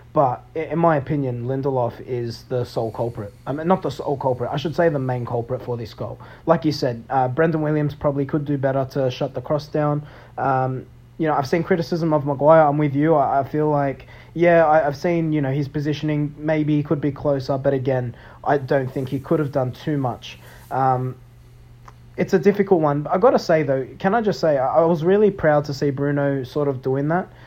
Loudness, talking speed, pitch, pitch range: -21 LUFS, 225 wpm, 145 Hz, 130-155 Hz